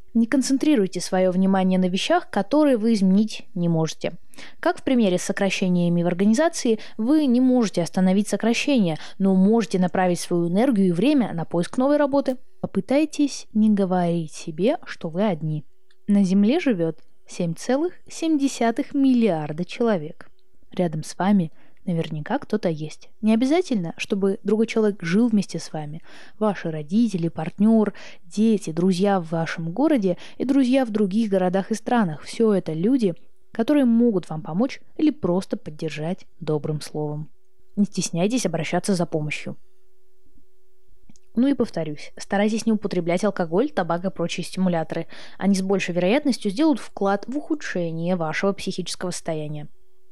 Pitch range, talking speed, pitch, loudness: 175-245 Hz, 140 wpm, 200 Hz, -22 LUFS